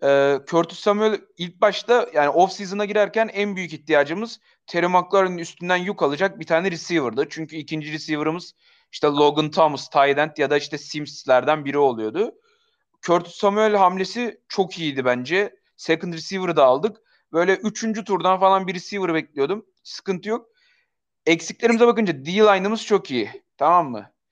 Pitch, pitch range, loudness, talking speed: 180 Hz, 155-210 Hz, -21 LUFS, 140 wpm